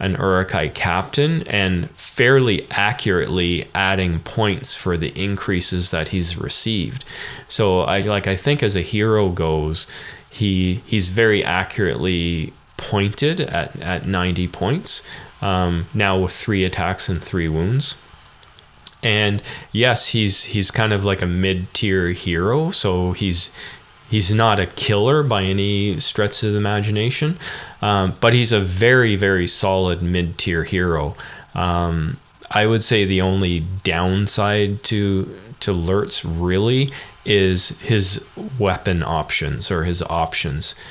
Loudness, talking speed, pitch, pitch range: -19 LUFS, 130 wpm, 95 Hz, 90-105 Hz